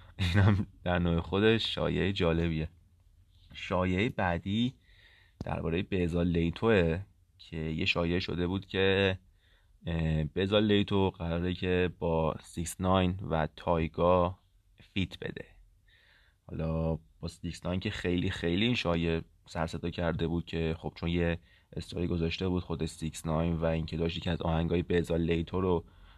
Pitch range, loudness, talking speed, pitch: 85-95 Hz, -31 LUFS, 130 wpm, 85 Hz